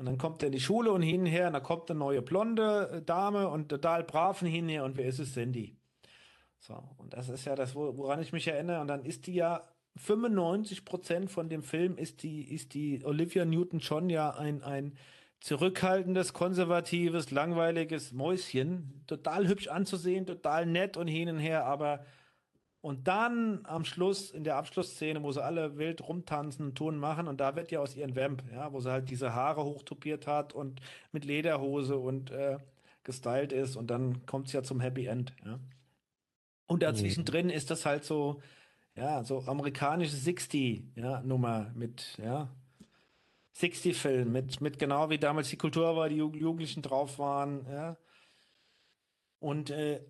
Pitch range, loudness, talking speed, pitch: 135-170 Hz, -34 LUFS, 175 wpm, 150 Hz